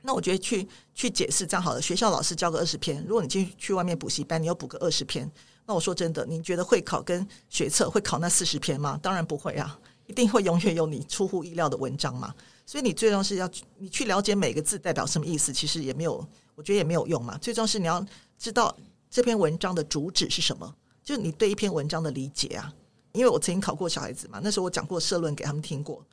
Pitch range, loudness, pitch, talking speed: 155-195 Hz, -27 LUFS, 175 Hz, 375 characters per minute